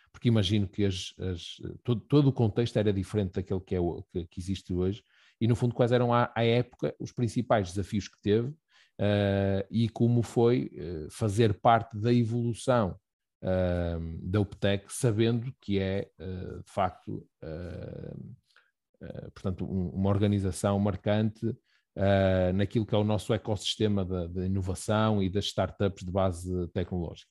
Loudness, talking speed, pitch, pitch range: -29 LUFS, 160 wpm, 100 Hz, 95-115 Hz